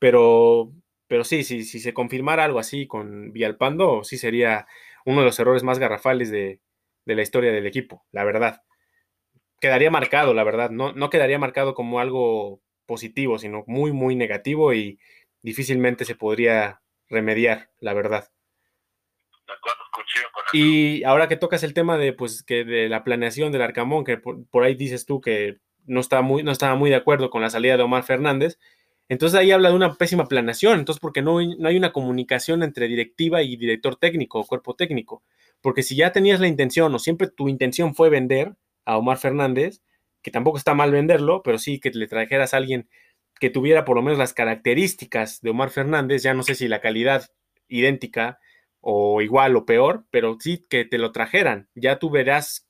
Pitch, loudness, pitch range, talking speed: 130 Hz, -21 LUFS, 115-150 Hz, 185 wpm